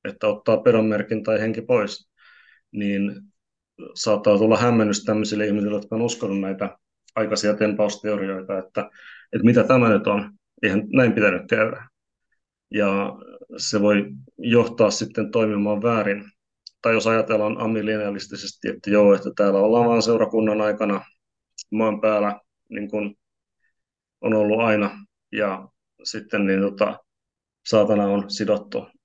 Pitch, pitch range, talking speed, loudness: 105 Hz, 100-110 Hz, 125 wpm, -21 LUFS